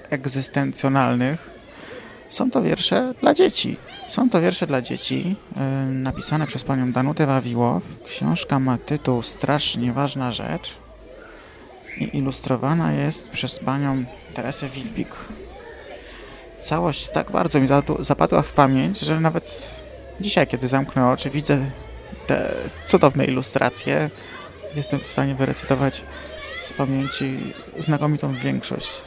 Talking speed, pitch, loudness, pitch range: 110 wpm, 135 Hz, -22 LUFS, 130-145 Hz